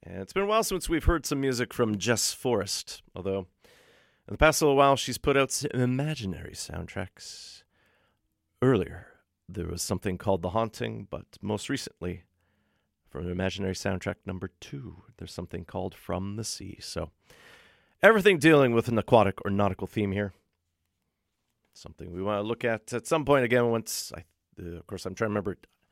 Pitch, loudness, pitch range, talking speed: 100 Hz, -27 LUFS, 90-125 Hz, 180 wpm